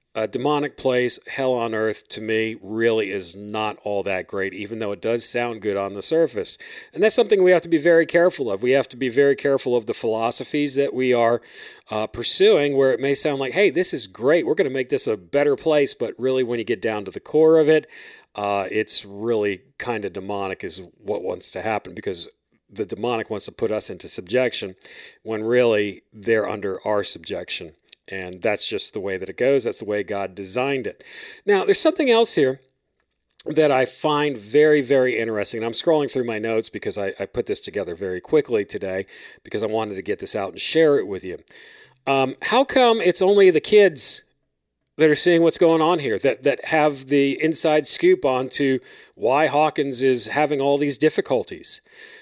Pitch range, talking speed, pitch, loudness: 115-185 Hz, 210 wpm, 140 Hz, -21 LUFS